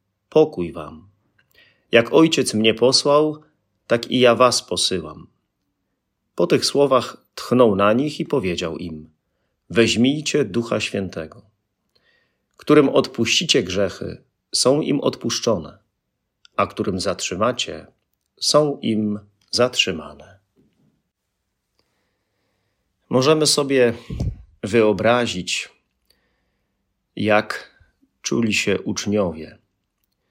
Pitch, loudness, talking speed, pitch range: 105 Hz, -19 LUFS, 85 wpm, 95-125 Hz